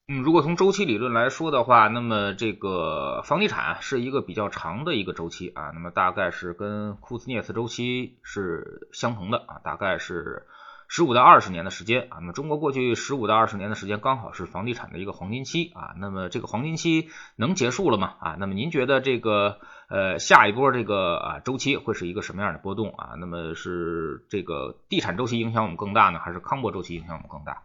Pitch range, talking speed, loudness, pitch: 90-125 Hz, 345 characters per minute, -24 LUFS, 105 Hz